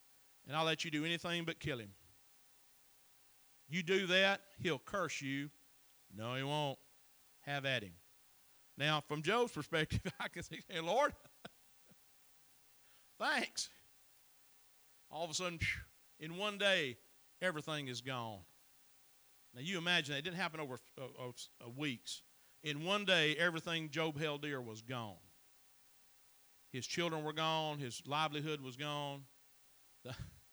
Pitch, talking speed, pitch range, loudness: 150 Hz, 140 wpm, 125-165 Hz, -39 LUFS